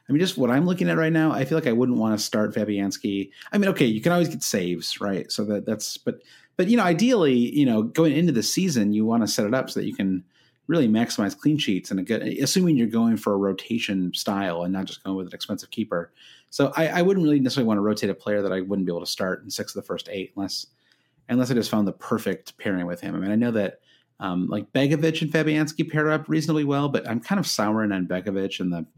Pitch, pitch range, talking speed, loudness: 115 Hz, 100-155 Hz, 270 wpm, -24 LUFS